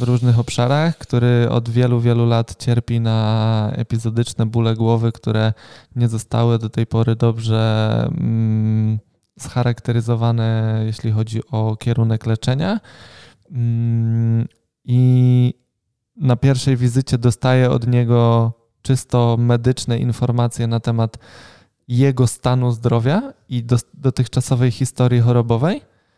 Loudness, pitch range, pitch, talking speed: -18 LUFS, 115-125 Hz, 120 Hz, 105 wpm